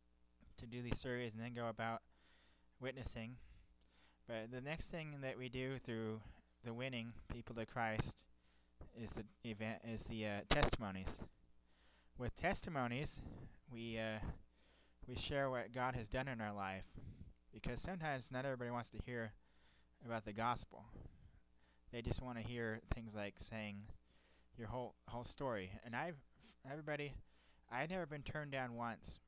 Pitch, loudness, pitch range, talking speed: 115 Hz, -46 LUFS, 85-125 Hz, 150 wpm